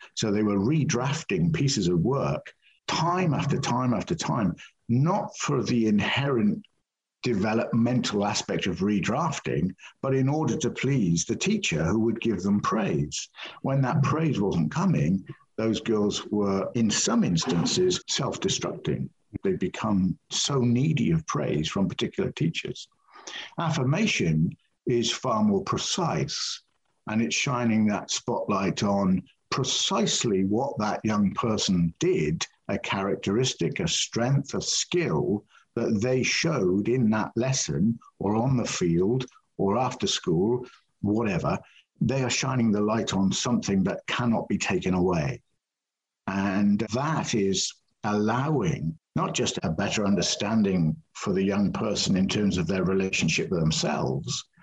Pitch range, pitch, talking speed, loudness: 100-140 Hz, 115 Hz, 135 wpm, -26 LUFS